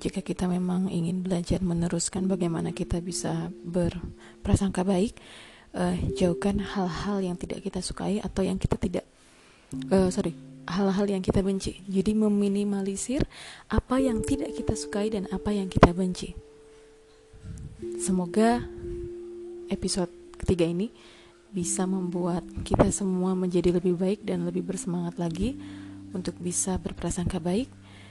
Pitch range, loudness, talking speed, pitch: 170-195 Hz, -28 LUFS, 125 wpm, 180 Hz